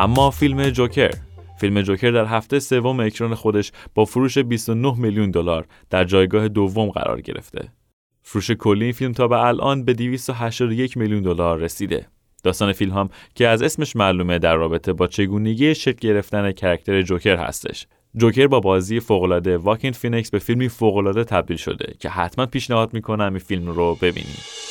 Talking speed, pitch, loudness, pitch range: 165 wpm, 110 Hz, -20 LUFS, 95-120 Hz